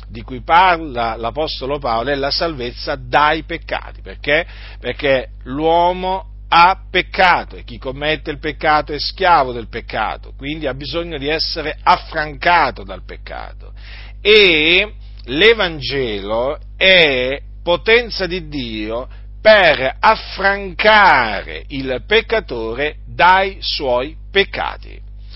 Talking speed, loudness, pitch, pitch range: 105 wpm, -15 LUFS, 145 Hz, 115-175 Hz